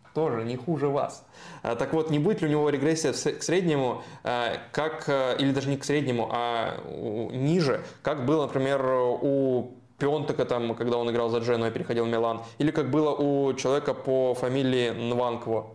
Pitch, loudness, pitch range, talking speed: 130 Hz, -27 LUFS, 120-145 Hz, 170 wpm